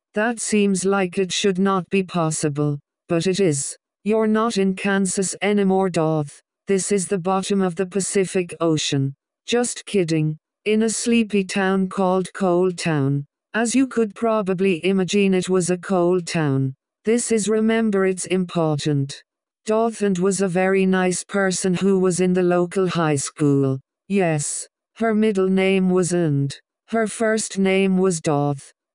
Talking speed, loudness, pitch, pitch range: 155 wpm, -21 LUFS, 190 Hz, 170-200 Hz